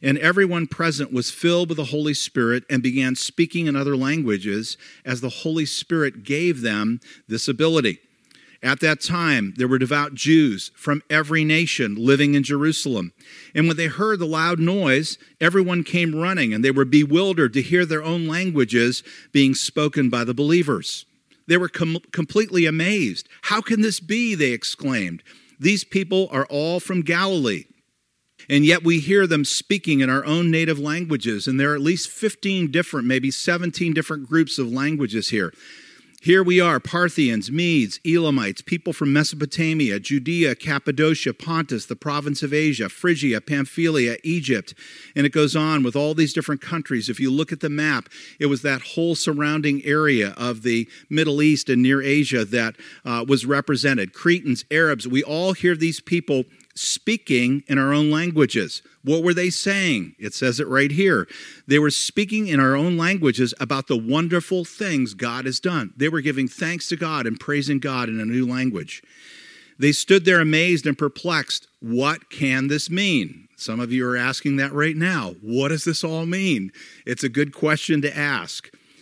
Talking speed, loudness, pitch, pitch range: 175 wpm, -21 LUFS, 150 Hz, 135-170 Hz